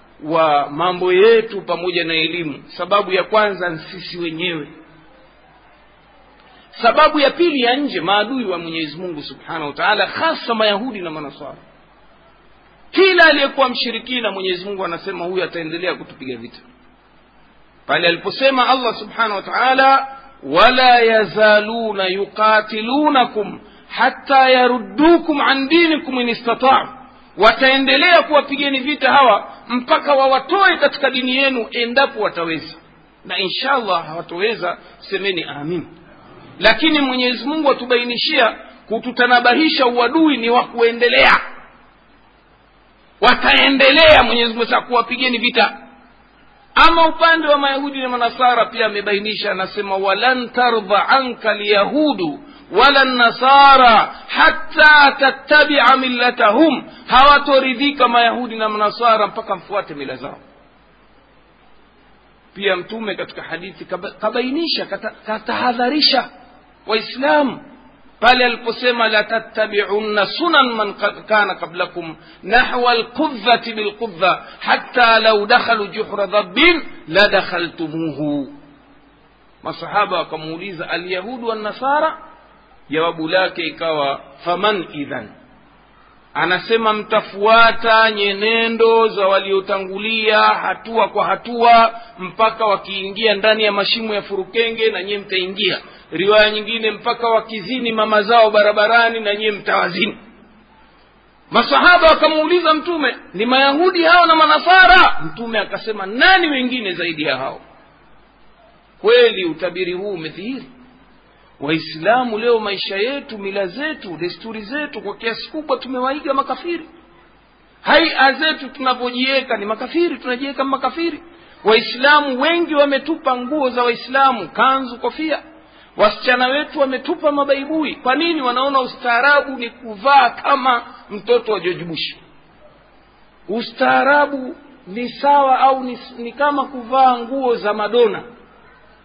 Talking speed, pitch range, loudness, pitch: 105 wpm, 205-275 Hz, -15 LUFS, 235 Hz